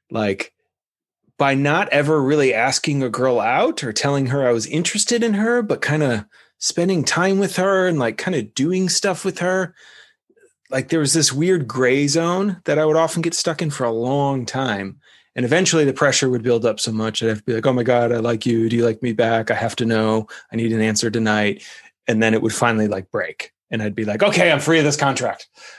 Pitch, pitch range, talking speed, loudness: 140 Hz, 115-170 Hz, 235 wpm, -19 LUFS